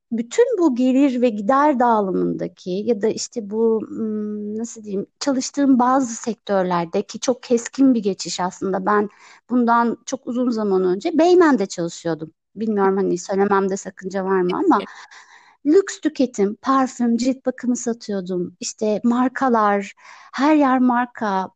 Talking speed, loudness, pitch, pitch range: 130 wpm, -20 LUFS, 230 Hz, 195-255 Hz